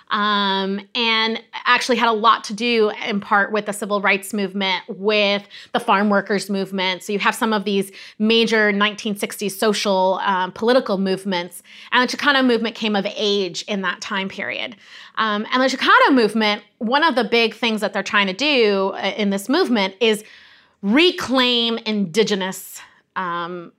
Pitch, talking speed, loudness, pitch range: 210 Hz, 165 wpm, -19 LUFS, 195-230 Hz